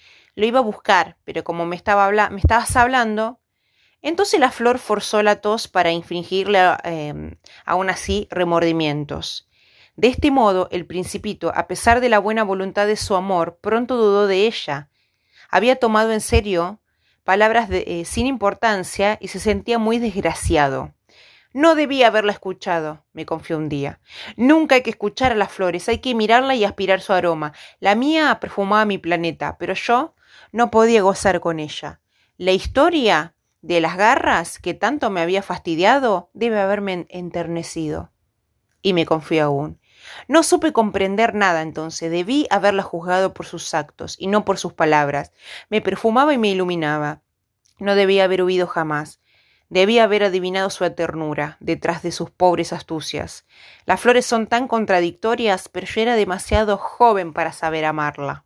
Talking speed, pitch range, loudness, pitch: 160 wpm, 170-220 Hz, -19 LUFS, 190 Hz